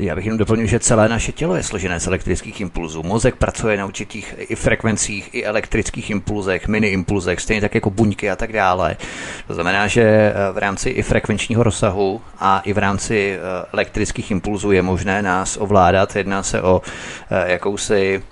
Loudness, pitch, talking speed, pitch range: -18 LUFS, 105 Hz, 175 wpm, 95-110 Hz